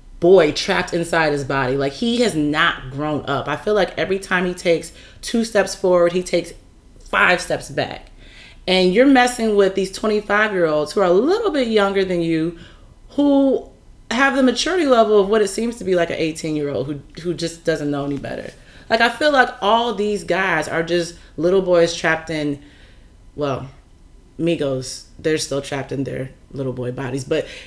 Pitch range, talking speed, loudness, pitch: 145-210 Hz, 195 wpm, -19 LUFS, 170 Hz